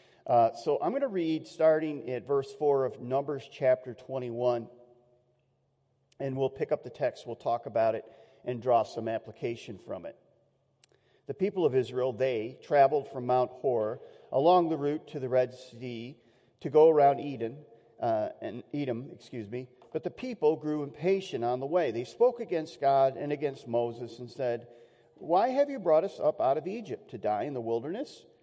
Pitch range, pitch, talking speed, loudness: 120-150 Hz, 135 Hz, 180 wpm, -30 LUFS